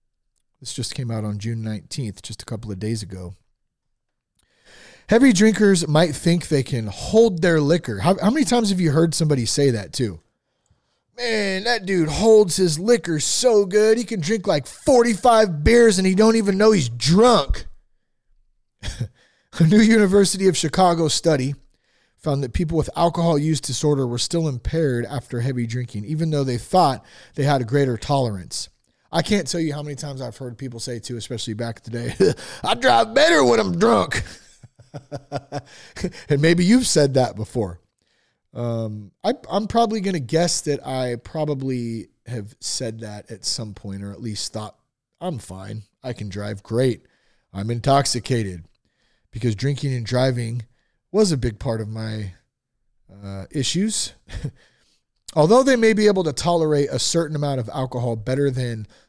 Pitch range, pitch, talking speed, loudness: 115-175 Hz, 140 Hz, 170 wpm, -20 LUFS